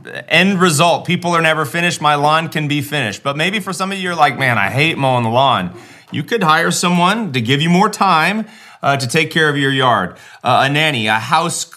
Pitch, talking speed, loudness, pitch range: 155 Hz, 235 wpm, -14 LUFS, 140-175 Hz